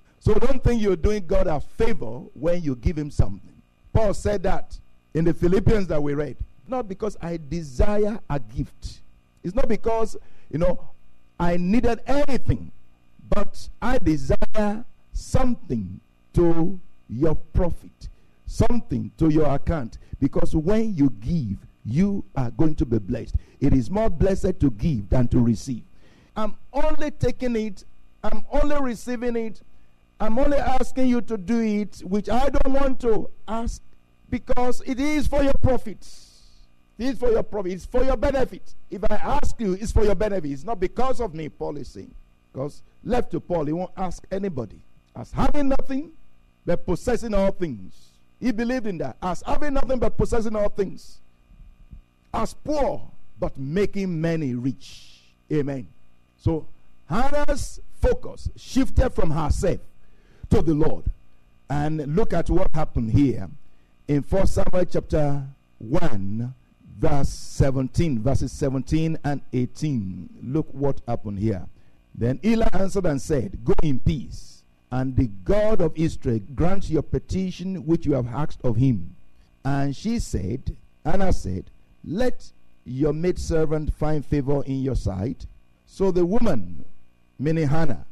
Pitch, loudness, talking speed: 160 Hz, -25 LUFS, 150 wpm